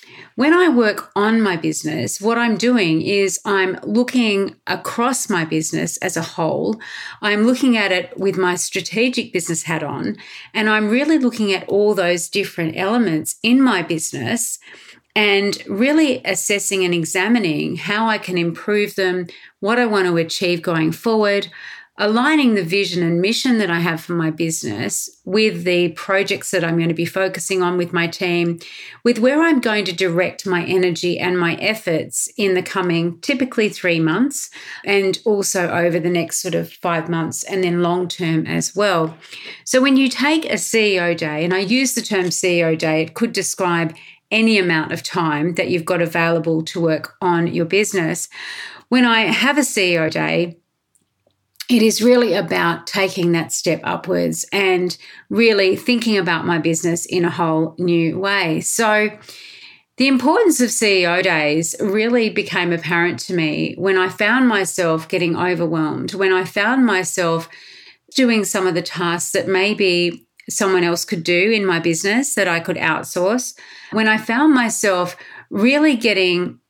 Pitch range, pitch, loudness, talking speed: 170-220 Hz, 185 Hz, -18 LUFS, 165 wpm